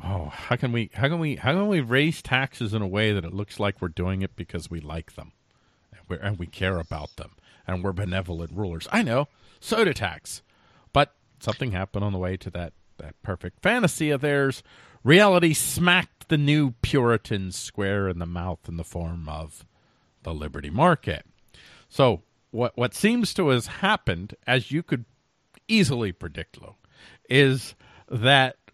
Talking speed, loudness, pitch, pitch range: 180 wpm, -24 LUFS, 110 Hz, 90-135 Hz